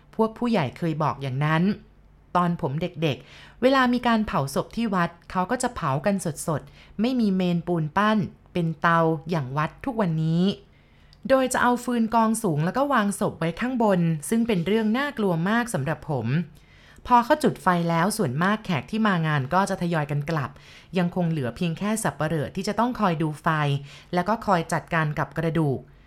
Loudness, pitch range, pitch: -24 LUFS, 160-215 Hz, 175 Hz